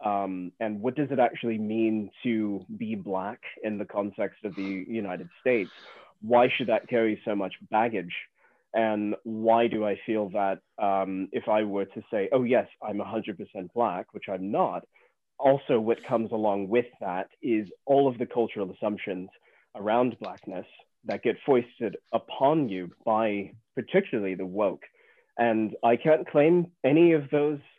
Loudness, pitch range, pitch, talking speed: -27 LUFS, 100-125 Hz, 110 Hz, 160 wpm